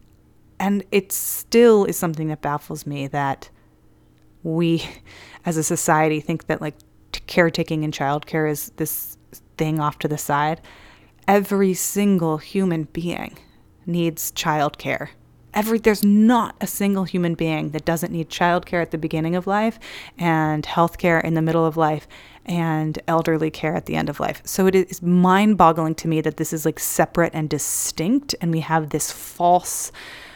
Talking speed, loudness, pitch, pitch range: 170 wpm, -21 LUFS, 165 Hz, 155-180 Hz